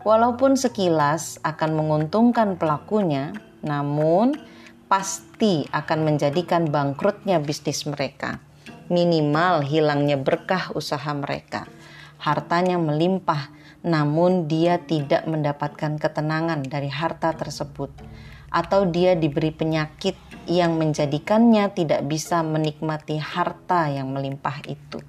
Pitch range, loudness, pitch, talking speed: 150-180 Hz, -22 LUFS, 160 Hz, 95 wpm